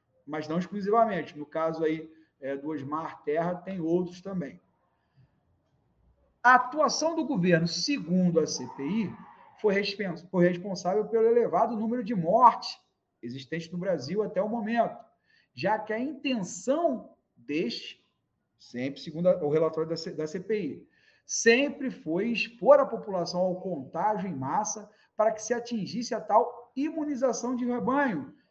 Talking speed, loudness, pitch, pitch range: 135 wpm, -28 LUFS, 200 Hz, 165-235 Hz